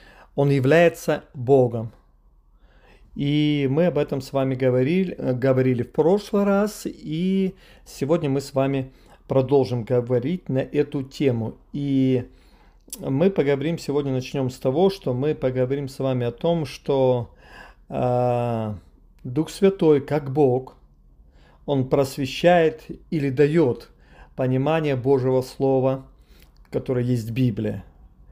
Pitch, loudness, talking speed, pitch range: 135 Hz, -22 LUFS, 115 wpm, 125-150 Hz